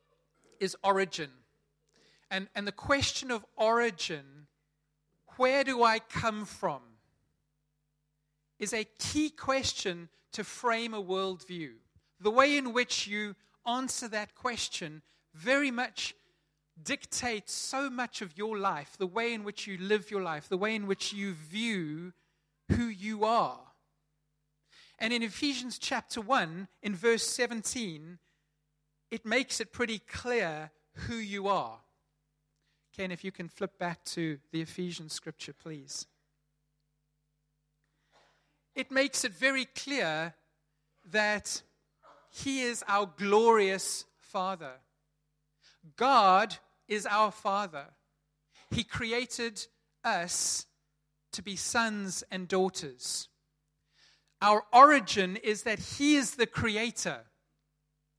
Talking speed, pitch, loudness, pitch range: 115 wpm, 195 Hz, -31 LUFS, 150-230 Hz